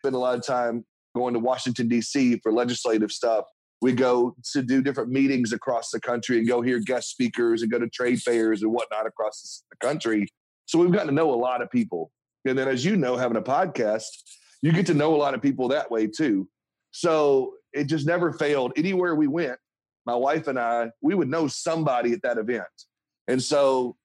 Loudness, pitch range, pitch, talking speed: -24 LUFS, 120-145 Hz, 125 Hz, 210 wpm